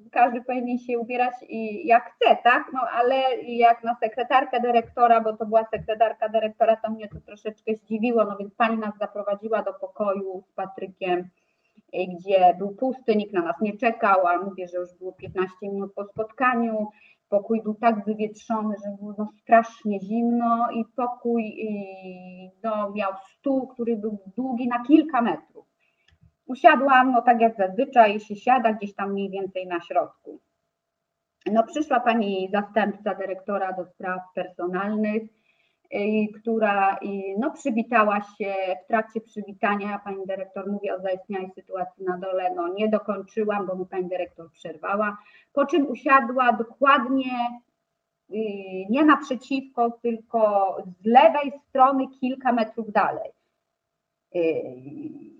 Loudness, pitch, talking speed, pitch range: -24 LUFS, 215 Hz, 140 wpm, 195-240 Hz